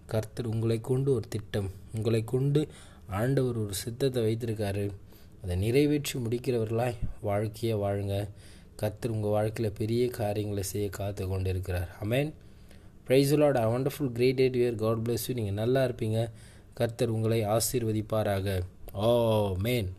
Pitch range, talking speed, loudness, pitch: 100-120 Hz, 115 wpm, -29 LUFS, 110 Hz